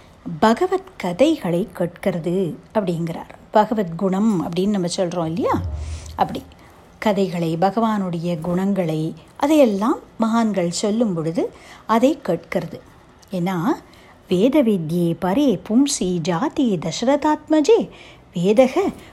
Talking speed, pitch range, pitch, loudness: 80 wpm, 175-245 Hz, 195 Hz, -20 LUFS